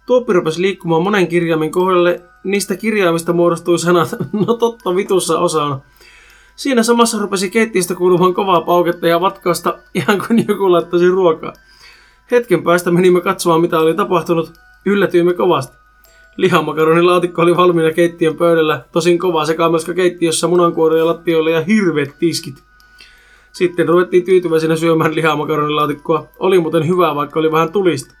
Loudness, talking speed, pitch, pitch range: -14 LUFS, 140 wpm, 175 Hz, 165-190 Hz